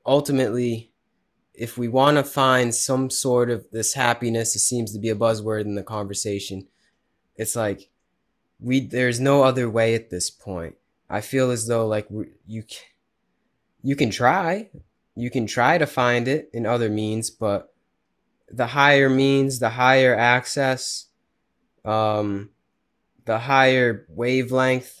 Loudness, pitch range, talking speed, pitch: -21 LUFS, 110-130 Hz, 145 wpm, 120 Hz